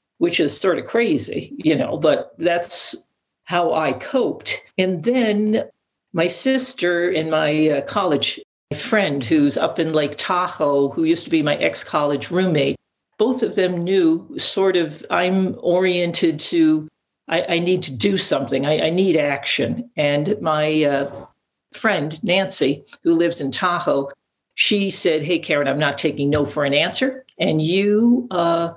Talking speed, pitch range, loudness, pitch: 155 wpm, 150-200 Hz, -19 LUFS, 175 Hz